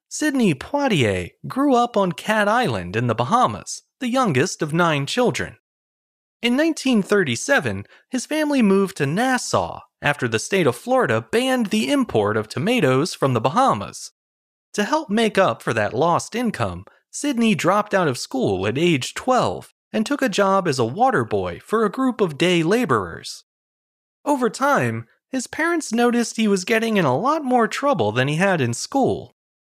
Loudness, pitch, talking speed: -20 LUFS, 210 Hz, 170 wpm